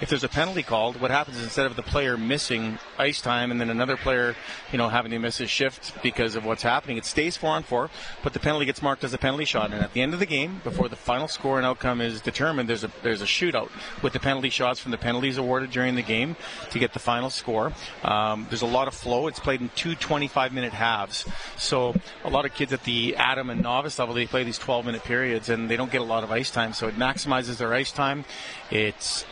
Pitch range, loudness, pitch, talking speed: 120-140 Hz, -26 LUFS, 125 Hz, 255 wpm